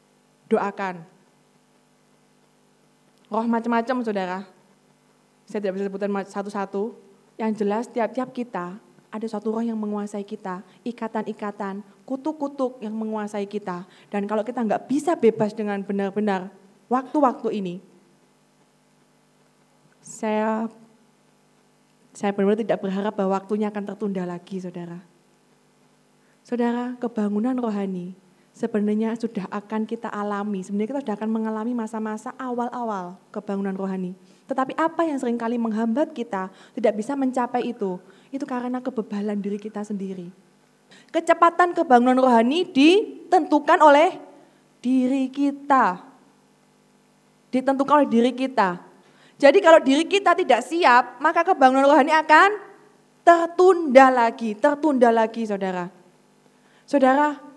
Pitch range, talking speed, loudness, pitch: 205-255 Hz, 110 wpm, -22 LUFS, 225 Hz